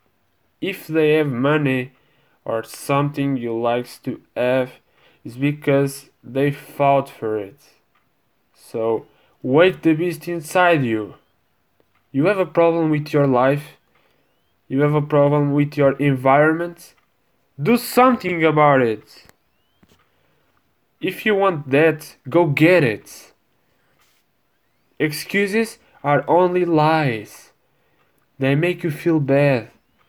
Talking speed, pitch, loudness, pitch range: 110 wpm, 145 Hz, -19 LUFS, 135-165 Hz